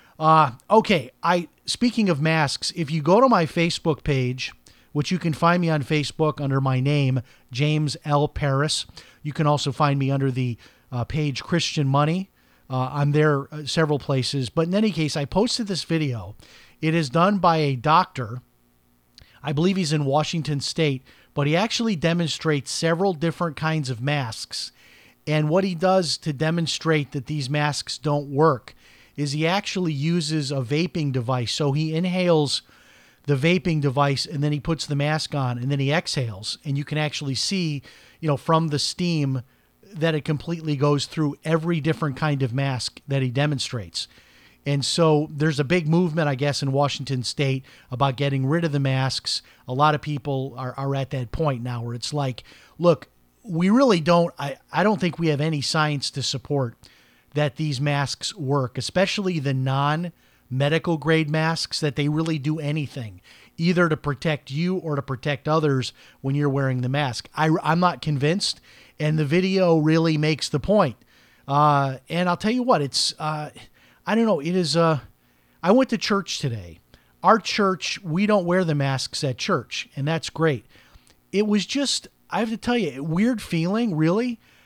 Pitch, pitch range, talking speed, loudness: 150 Hz, 135-165 Hz, 175 wpm, -23 LUFS